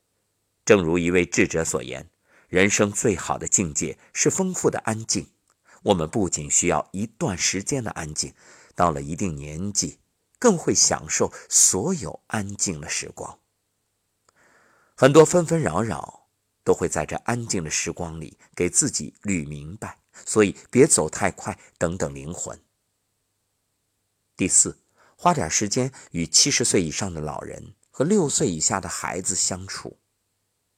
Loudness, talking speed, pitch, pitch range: -22 LUFS, 210 characters per minute, 100 Hz, 85-110 Hz